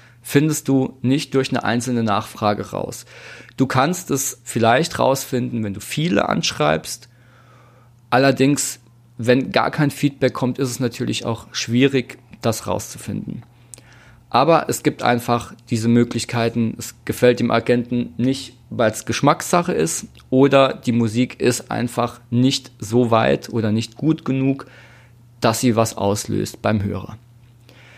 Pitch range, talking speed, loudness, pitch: 115-130 Hz, 135 wpm, -19 LUFS, 120 Hz